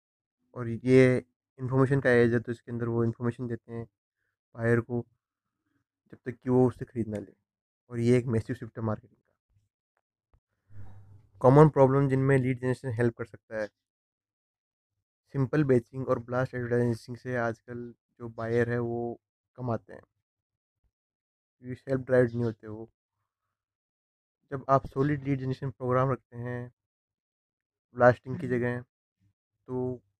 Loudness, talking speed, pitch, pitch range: -28 LUFS, 145 wpm, 120 Hz, 110-125 Hz